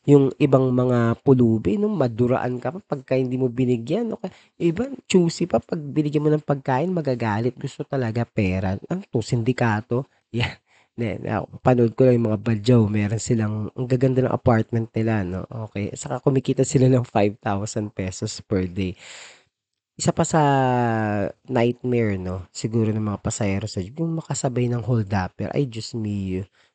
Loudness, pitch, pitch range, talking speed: -22 LUFS, 125 Hz, 110-140 Hz, 160 wpm